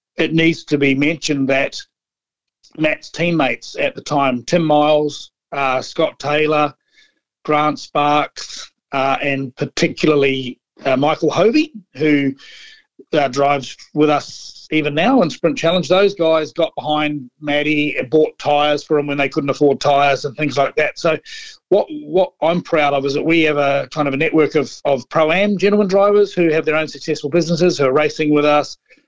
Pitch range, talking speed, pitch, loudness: 140-165 Hz, 175 wpm, 150 Hz, -16 LUFS